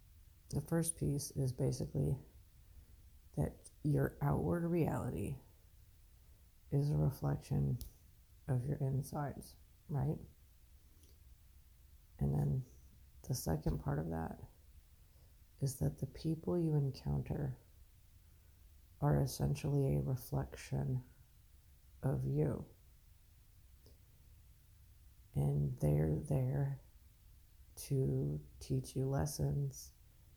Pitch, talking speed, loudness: 90 Hz, 85 wpm, -39 LUFS